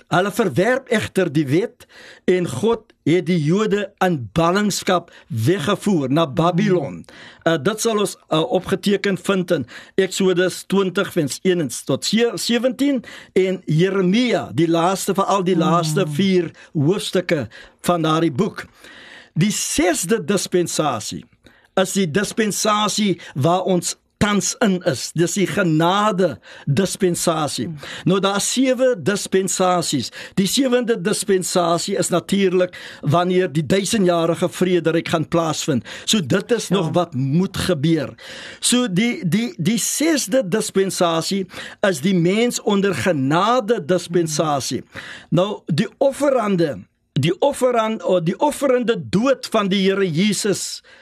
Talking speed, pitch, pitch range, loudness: 120 wpm, 185 Hz, 170-205 Hz, -19 LUFS